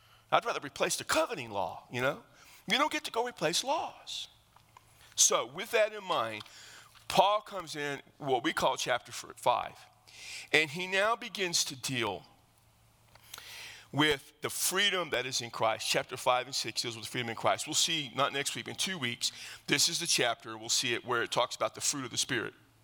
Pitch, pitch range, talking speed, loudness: 150 Hz, 125-190 Hz, 195 wpm, -31 LUFS